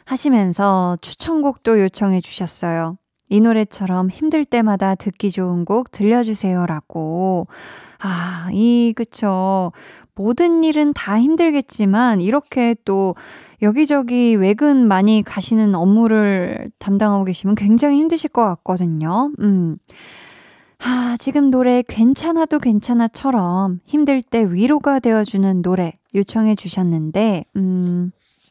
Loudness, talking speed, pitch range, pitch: -17 LUFS, 255 characters per minute, 185-245 Hz, 210 Hz